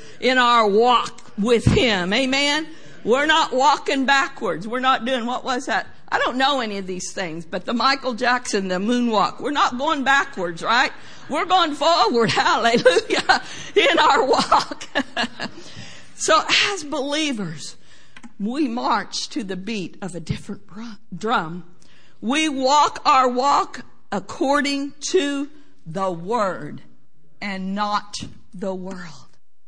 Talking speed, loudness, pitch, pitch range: 130 wpm, -20 LUFS, 250 Hz, 200-285 Hz